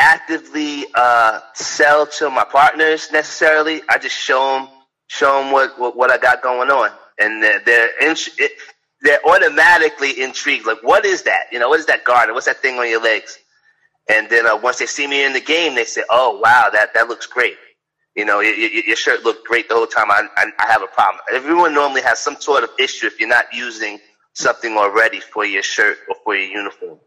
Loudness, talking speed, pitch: -15 LUFS, 215 wpm, 175 Hz